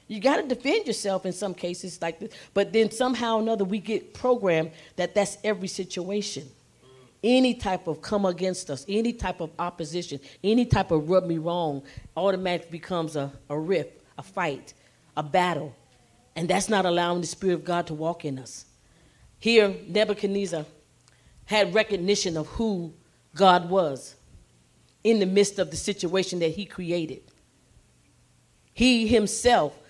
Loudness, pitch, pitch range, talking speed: -26 LUFS, 185 Hz, 160-205 Hz, 155 wpm